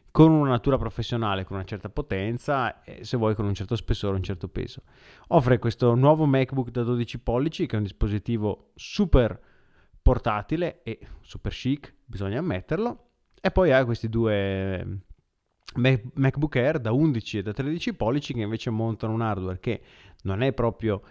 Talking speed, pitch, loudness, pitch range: 165 wpm, 115 Hz, -26 LUFS, 105-130 Hz